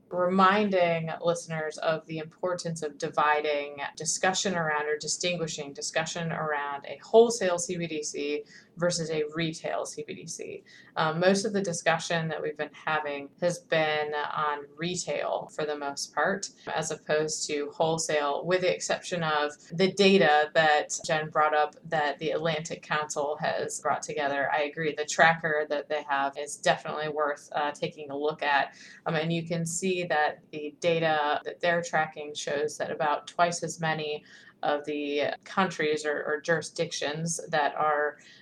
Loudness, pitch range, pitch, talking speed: -28 LUFS, 150-170 Hz, 155 Hz, 155 wpm